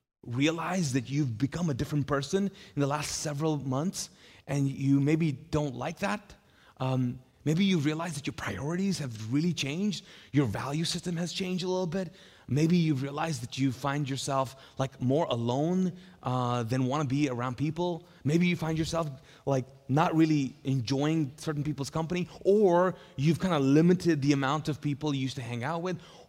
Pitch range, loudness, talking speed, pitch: 135-170 Hz, -30 LUFS, 180 wpm, 150 Hz